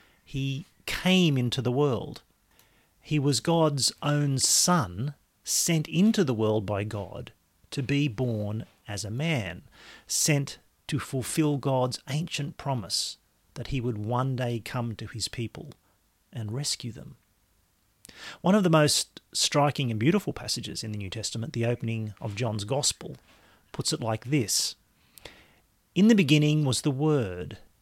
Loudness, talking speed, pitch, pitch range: -27 LUFS, 145 wpm, 125 Hz, 110-150 Hz